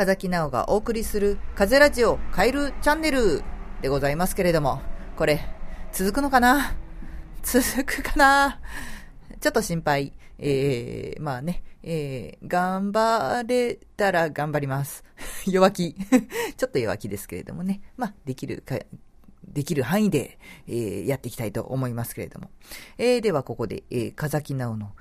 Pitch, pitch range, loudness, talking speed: 175 Hz, 135-225 Hz, -24 LUFS, 290 characters per minute